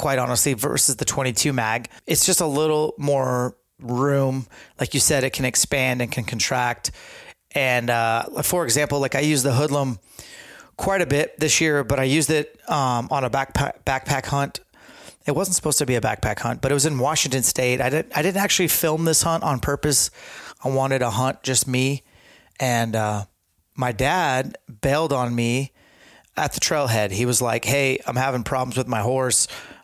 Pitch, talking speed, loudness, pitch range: 135 Hz, 190 wpm, -21 LUFS, 125-150 Hz